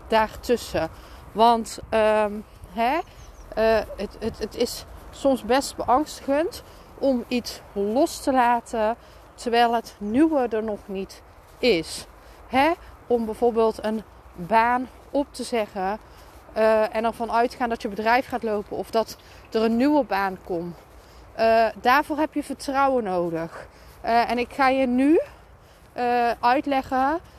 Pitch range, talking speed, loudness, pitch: 220-265 Hz, 140 wpm, -23 LUFS, 235 Hz